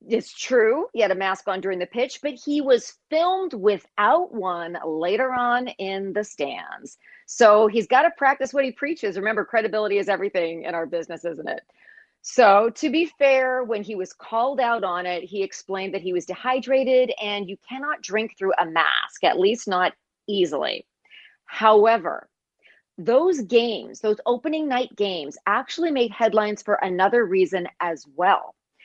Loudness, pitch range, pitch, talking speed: -22 LUFS, 190-265 Hz, 220 Hz, 170 wpm